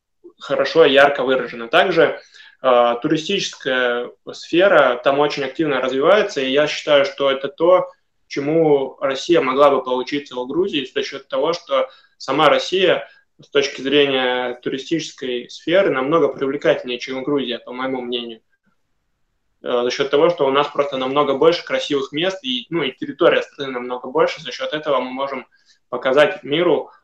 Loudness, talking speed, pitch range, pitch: -18 LUFS, 150 wpm, 130-190 Hz, 145 Hz